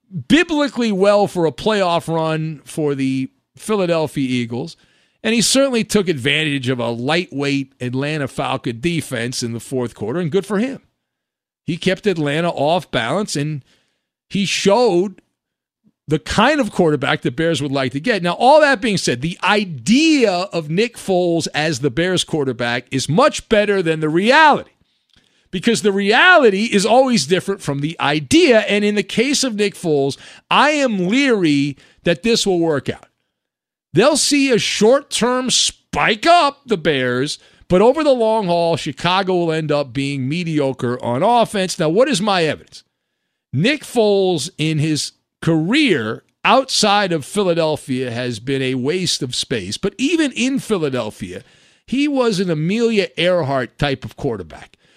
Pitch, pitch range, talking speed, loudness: 175 Hz, 145-215 Hz, 155 wpm, -17 LUFS